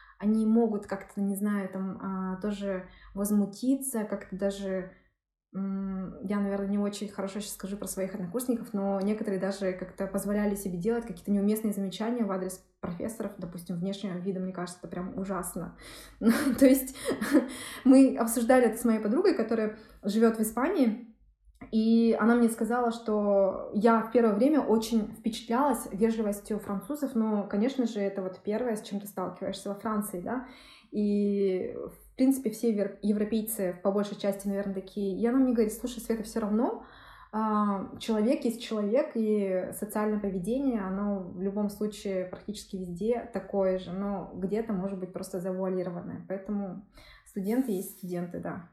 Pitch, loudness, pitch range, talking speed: 205 Hz, -29 LUFS, 195-230 Hz, 155 wpm